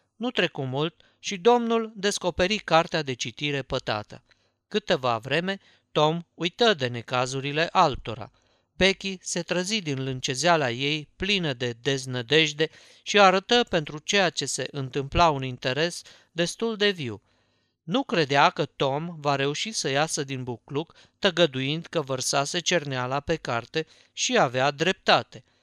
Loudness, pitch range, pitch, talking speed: -25 LUFS, 130-180 Hz, 155 Hz, 135 wpm